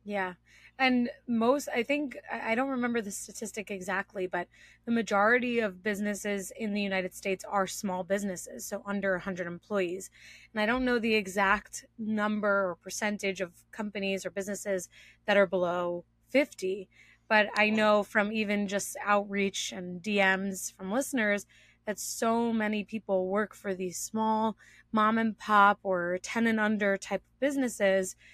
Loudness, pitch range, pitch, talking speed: -30 LUFS, 195-220 Hz, 205 Hz, 155 wpm